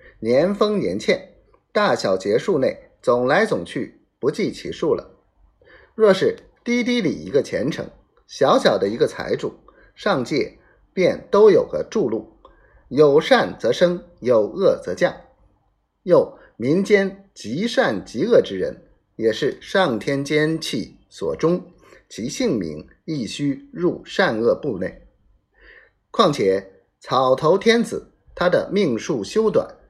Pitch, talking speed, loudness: 230 Hz, 180 characters per minute, -20 LUFS